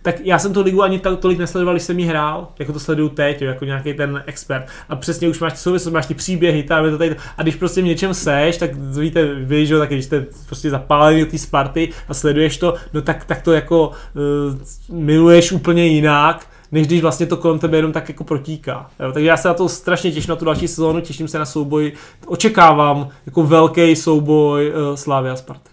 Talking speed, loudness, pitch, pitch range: 230 wpm, -16 LUFS, 160 Hz, 150-170 Hz